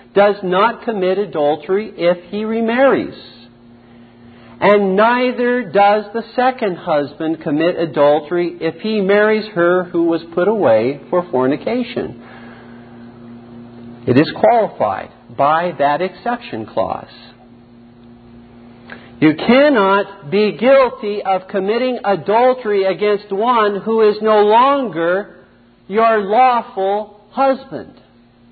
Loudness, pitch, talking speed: -15 LUFS, 185 Hz, 100 wpm